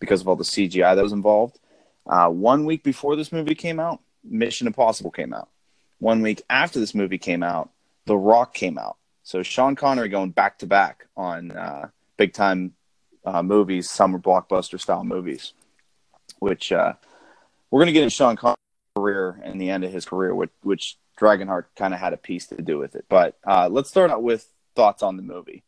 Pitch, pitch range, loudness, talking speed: 105 Hz, 95-135 Hz, -21 LUFS, 200 wpm